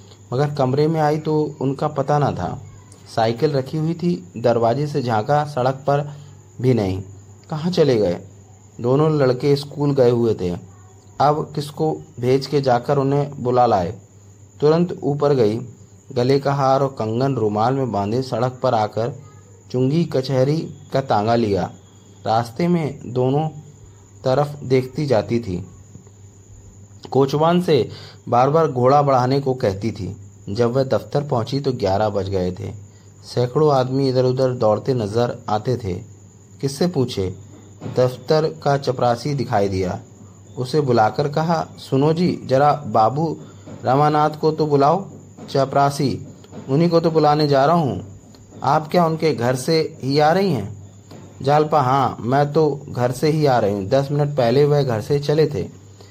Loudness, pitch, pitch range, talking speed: -19 LUFS, 130 Hz, 105-145 Hz, 150 wpm